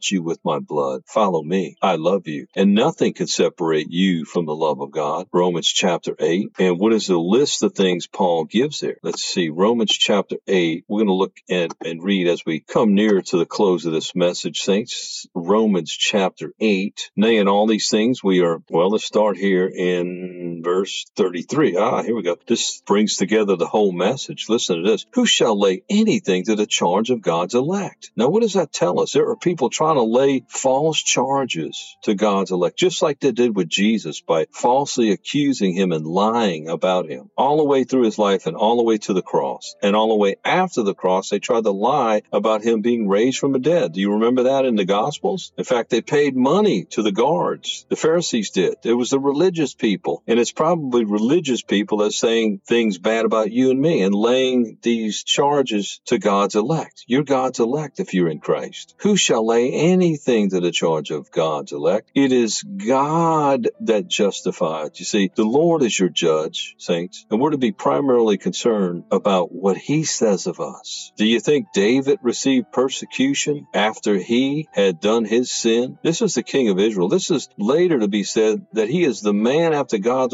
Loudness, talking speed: -19 LUFS, 205 wpm